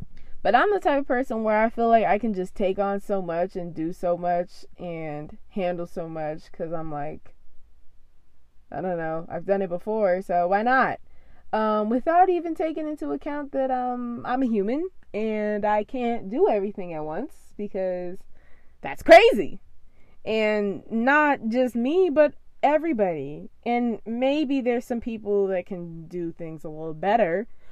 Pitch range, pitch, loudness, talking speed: 175-250 Hz, 205 Hz, -24 LUFS, 165 wpm